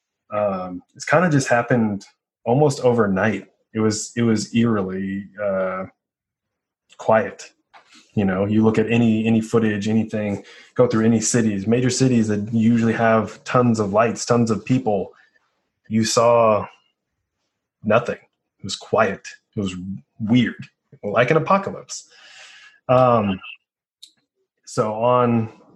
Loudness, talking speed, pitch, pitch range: -20 LUFS, 125 wpm, 110 Hz, 105-120 Hz